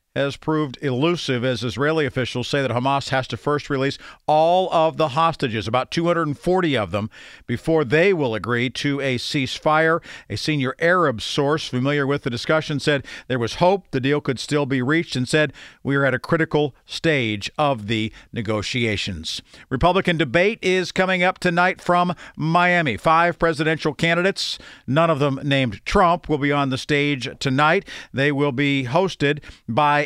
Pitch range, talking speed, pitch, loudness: 130-165 Hz, 170 wpm, 145 Hz, -21 LUFS